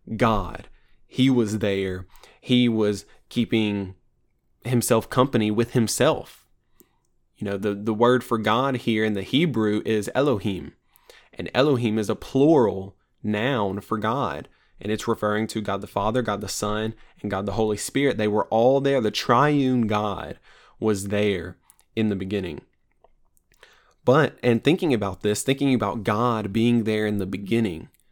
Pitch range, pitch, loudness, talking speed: 100-120 Hz, 110 Hz, -23 LUFS, 155 wpm